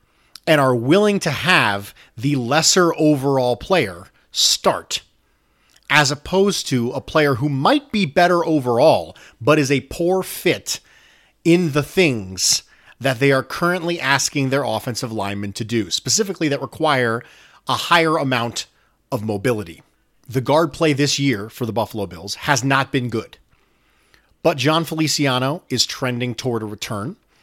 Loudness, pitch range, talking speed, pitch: -19 LUFS, 120-160 Hz, 145 wpm, 135 Hz